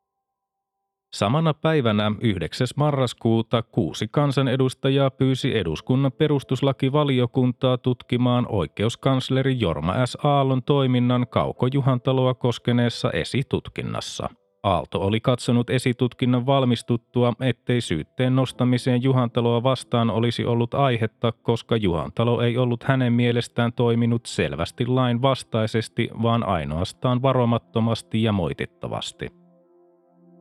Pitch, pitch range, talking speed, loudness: 125 Hz, 115-135 Hz, 90 wpm, -22 LUFS